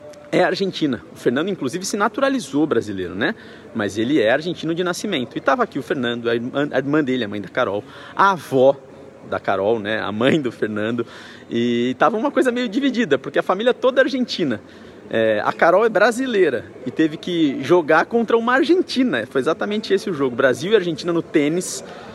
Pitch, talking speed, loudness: 170 Hz, 190 wpm, -20 LUFS